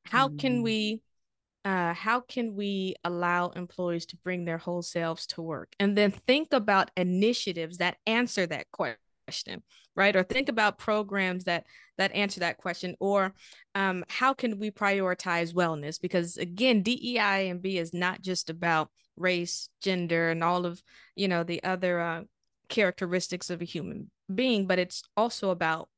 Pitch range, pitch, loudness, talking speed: 175-205 Hz, 185 Hz, -29 LUFS, 160 wpm